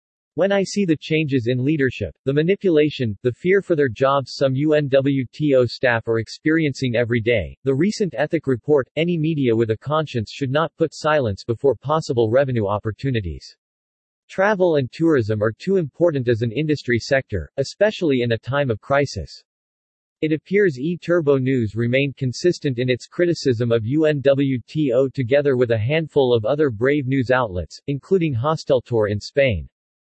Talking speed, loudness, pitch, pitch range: 155 wpm, -20 LUFS, 135 Hz, 115-155 Hz